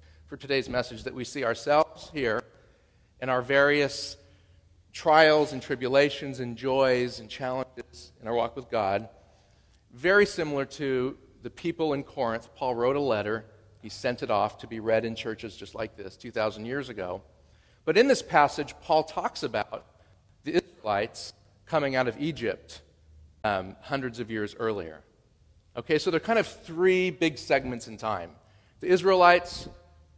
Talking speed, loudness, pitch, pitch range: 155 wpm, -27 LUFS, 120 Hz, 100-140 Hz